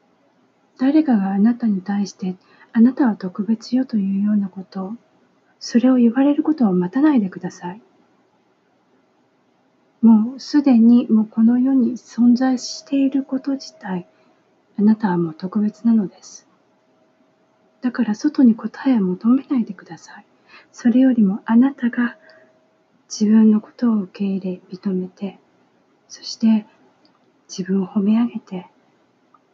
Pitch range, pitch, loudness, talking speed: 200-255 Hz, 225 Hz, -18 LUFS, 260 characters per minute